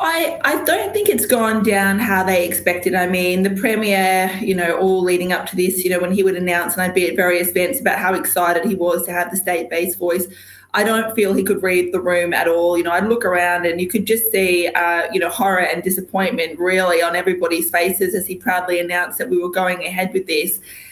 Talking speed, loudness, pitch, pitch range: 245 wpm, -17 LUFS, 185 Hz, 175-195 Hz